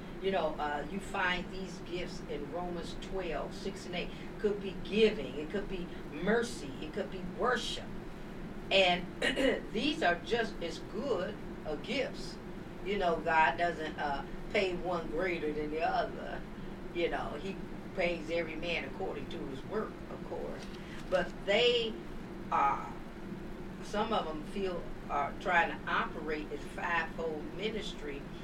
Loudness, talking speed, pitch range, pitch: -35 LUFS, 150 wpm, 175-195 Hz, 185 Hz